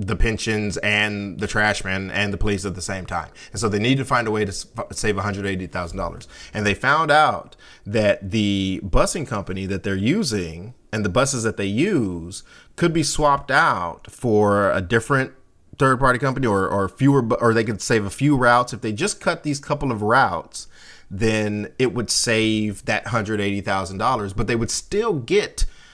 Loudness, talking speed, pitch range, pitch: -21 LUFS, 195 wpm, 100-125 Hz, 105 Hz